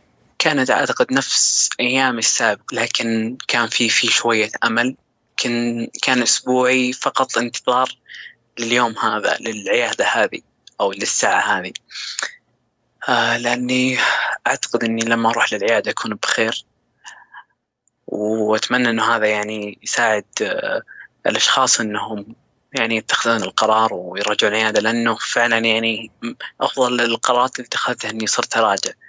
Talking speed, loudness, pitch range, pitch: 115 wpm, -18 LUFS, 110-125 Hz, 115 Hz